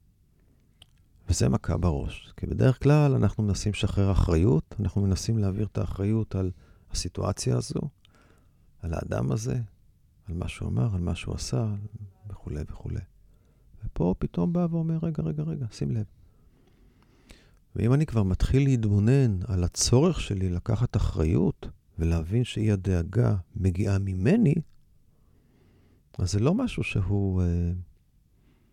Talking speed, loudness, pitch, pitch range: 125 wpm, -27 LUFS, 100 Hz, 90-115 Hz